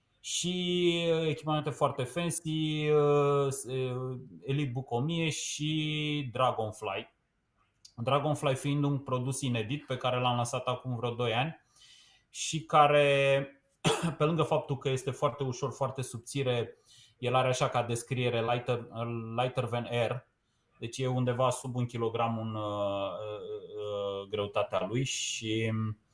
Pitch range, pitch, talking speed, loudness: 120-145 Hz, 130 Hz, 125 wpm, -31 LUFS